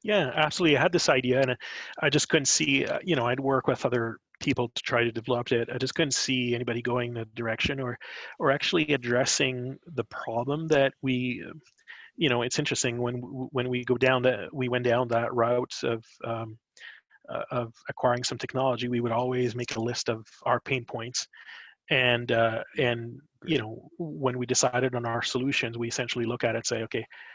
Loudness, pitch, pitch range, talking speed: -27 LUFS, 125 Hz, 120-130 Hz, 195 wpm